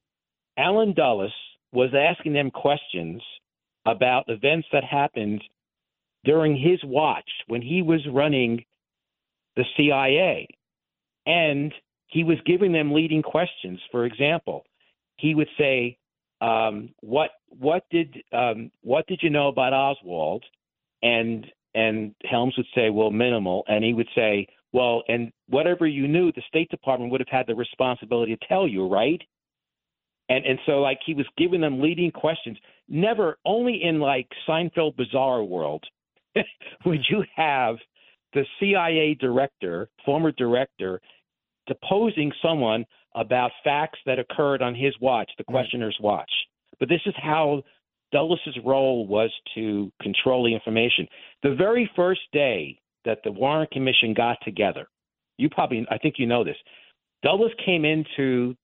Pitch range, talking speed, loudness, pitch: 120-155 Hz, 140 wpm, -23 LUFS, 135 Hz